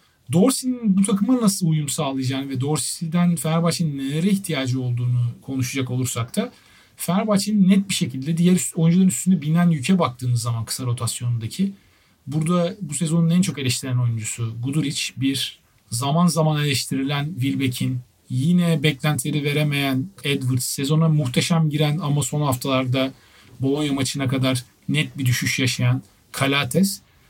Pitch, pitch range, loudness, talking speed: 140 Hz, 125-165 Hz, -21 LUFS, 130 wpm